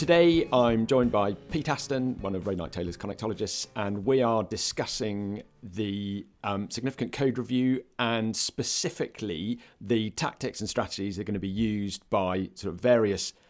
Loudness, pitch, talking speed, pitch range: -28 LUFS, 110 Hz, 165 wpm, 100-125 Hz